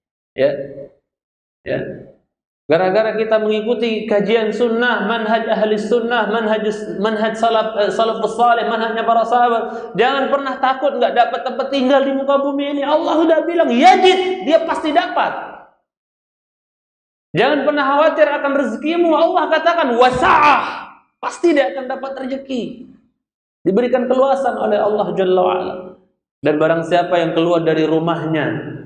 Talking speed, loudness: 130 wpm, -16 LUFS